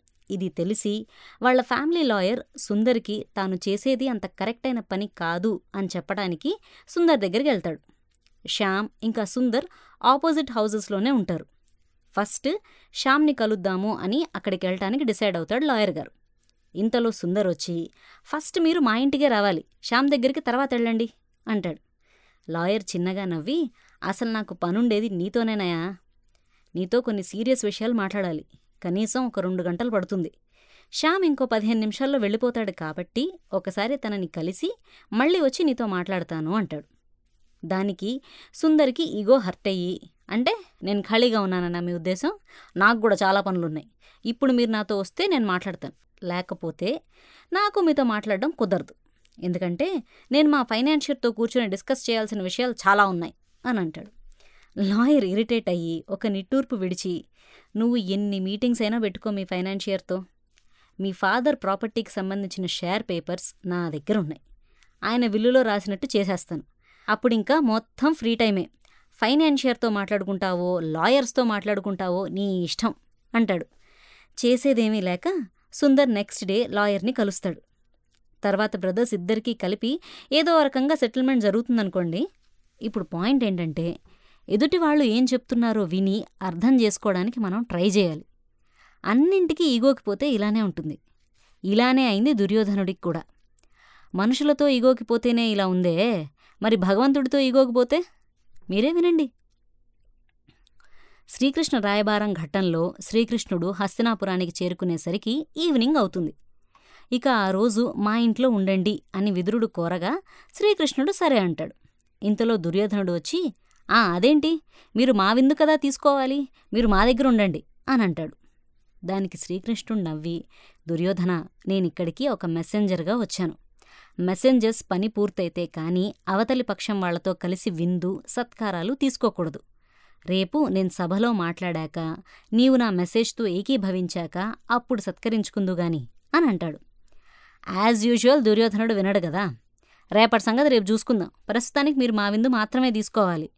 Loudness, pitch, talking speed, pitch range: -24 LUFS, 215 Hz, 115 wpm, 185-250 Hz